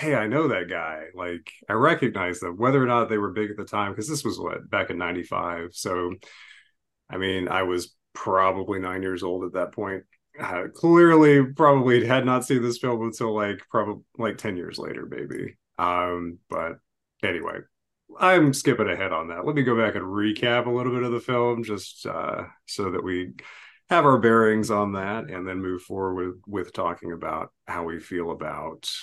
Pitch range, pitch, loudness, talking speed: 95-125 Hz, 105 Hz, -24 LUFS, 195 wpm